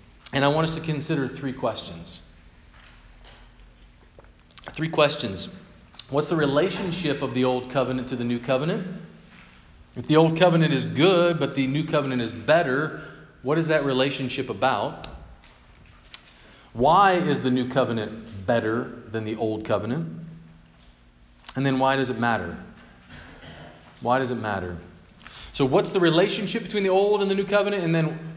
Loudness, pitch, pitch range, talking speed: -24 LUFS, 130 Hz, 110-160 Hz, 150 wpm